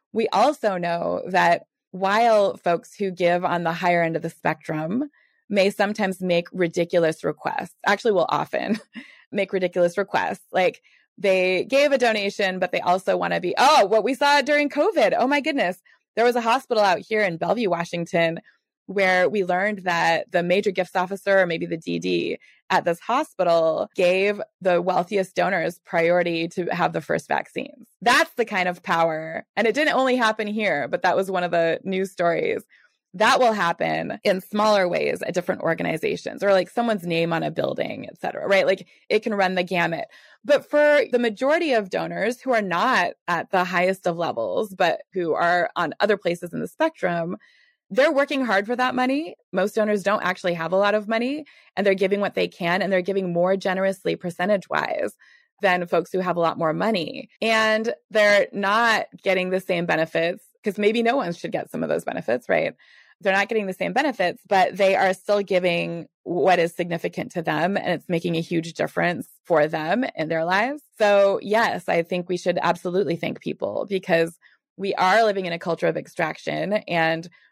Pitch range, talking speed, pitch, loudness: 175-220 Hz, 190 wpm, 190 Hz, -22 LUFS